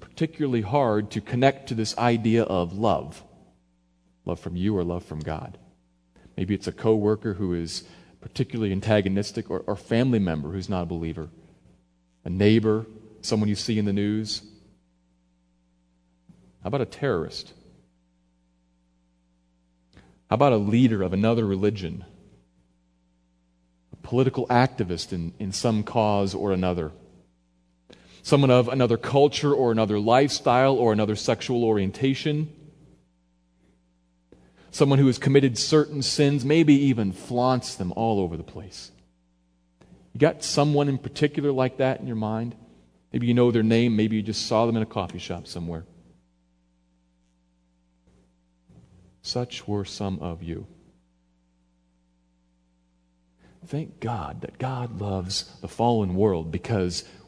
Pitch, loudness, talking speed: 95 Hz, -24 LUFS, 130 wpm